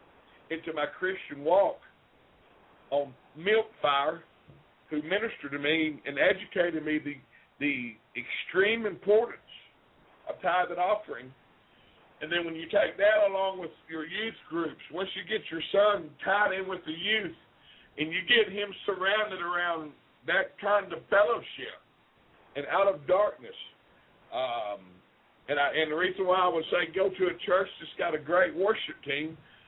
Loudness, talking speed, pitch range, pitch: -29 LUFS, 155 wpm, 155-195 Hz, 175 Hz